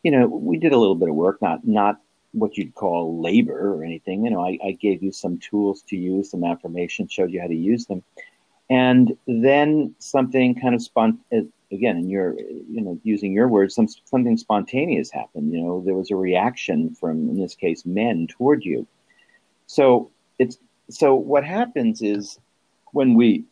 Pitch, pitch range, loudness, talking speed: 105 Hz, 90-135 Hz, -21 LUFS, 190 wpm